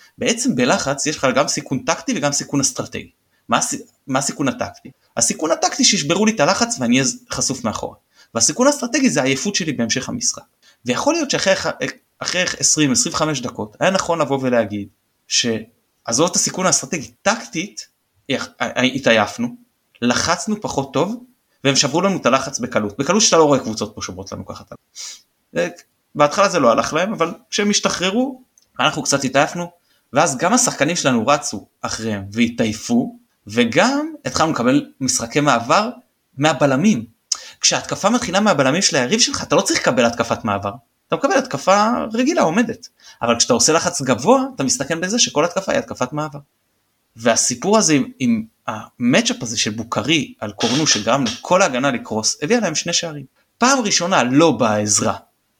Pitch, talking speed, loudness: 155 Hz, 155 wpm, -18 LUFS